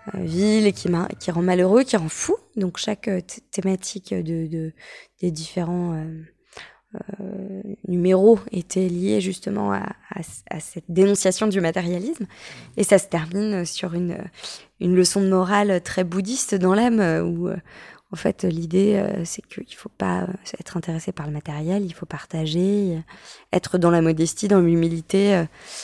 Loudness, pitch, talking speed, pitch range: -22 LUFS, 185 Hz, 150 wpm, 170-200 Hz